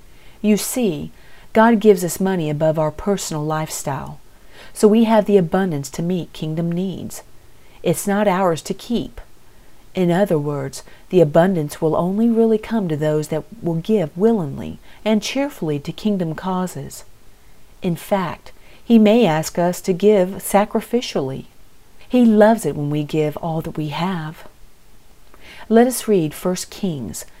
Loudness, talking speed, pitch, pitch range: -19 LUFS, 150 wpm, 185 Hz, 155-210 Hz